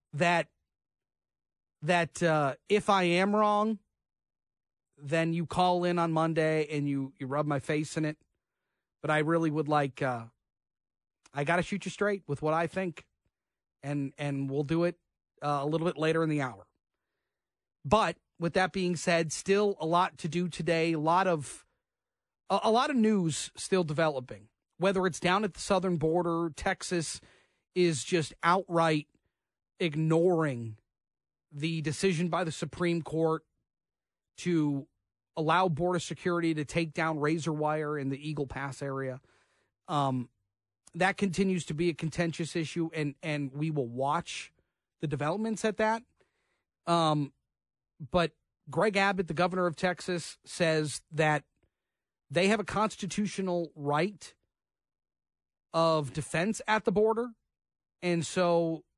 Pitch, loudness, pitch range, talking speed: 165 Hz, -30 LUFS, 145-180 Hz, 145 wpm